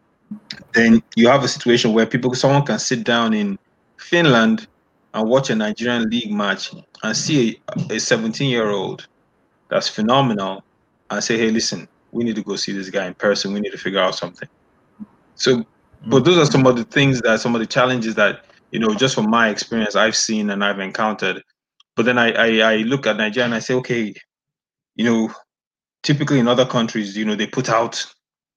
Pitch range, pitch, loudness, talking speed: 110-125 Hz, 115 Hz, -18 LUFS, 200 wpm